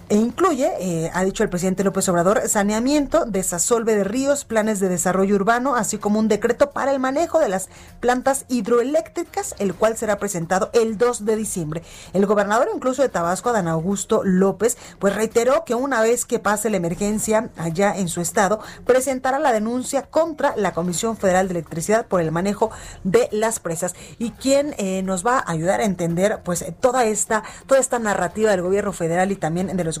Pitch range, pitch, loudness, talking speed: 185-240 Hz, 215 Hz, -20 LUFS, 190 wpm